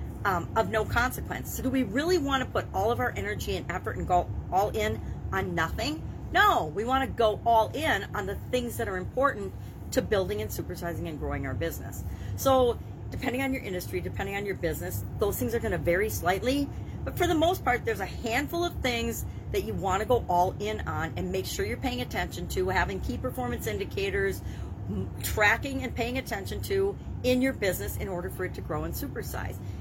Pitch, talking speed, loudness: 190 Hz, 210 wpm, -29 LUFS